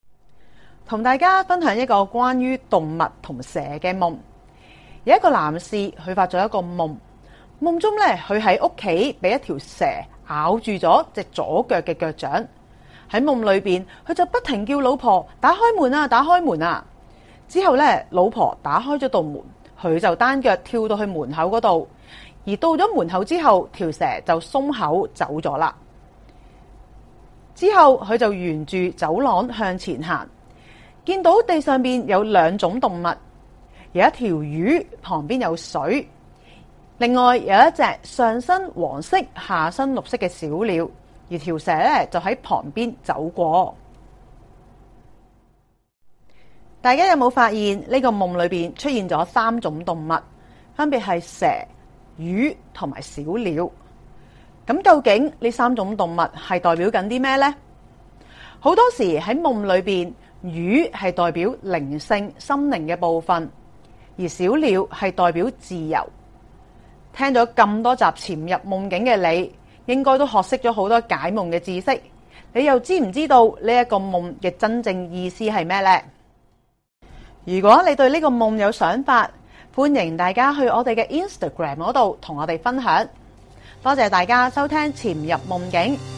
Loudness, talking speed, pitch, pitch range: -20 LUFS, 215 characters per minute, 210 Hz, 175-260 Hz